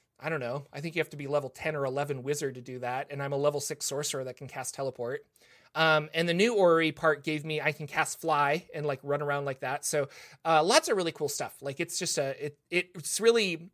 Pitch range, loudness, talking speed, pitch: 140-160 Hz, -30 LUFS, 260 wpm, 150 Hz